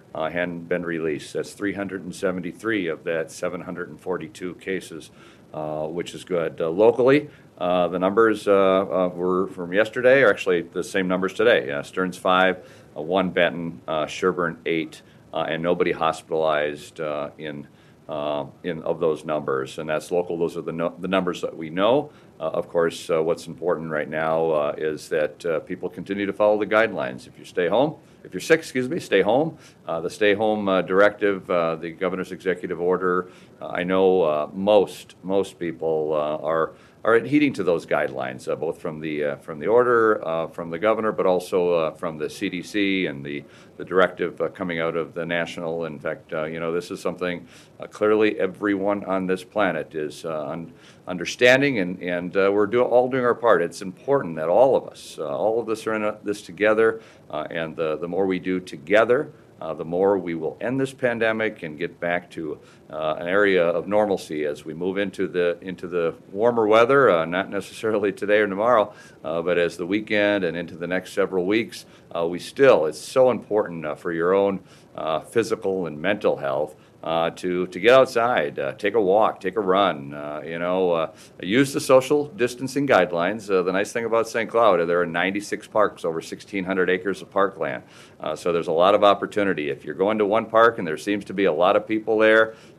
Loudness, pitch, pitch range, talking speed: -23 LUFS, 90 Hz, 85-105 Hz, 200 wpm